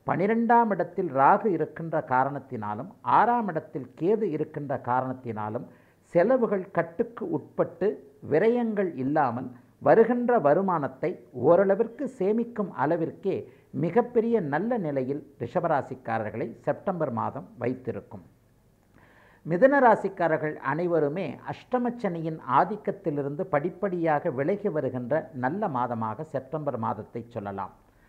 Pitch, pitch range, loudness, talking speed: 155 Hz, 125-200 Hz, -27 LUFS, 85 wpm